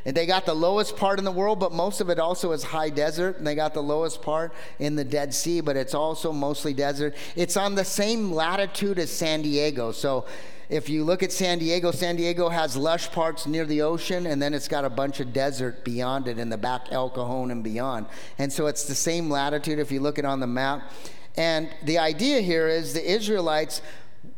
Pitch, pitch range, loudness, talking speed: 155 Hz, 145-170 Hz, -26 LUFS, 225 wpm